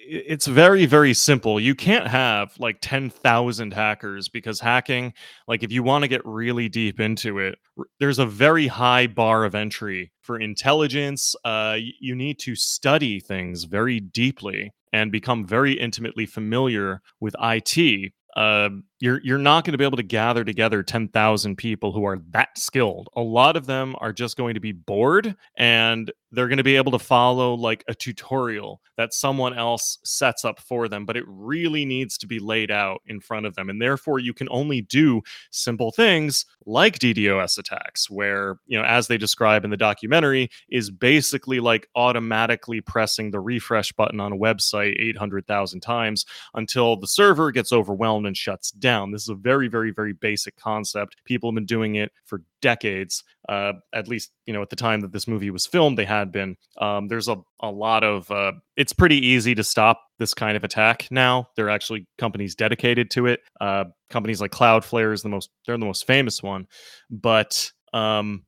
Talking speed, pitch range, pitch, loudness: 185 wpm, 105-125 Hz, 115 Hz, -21 LUFS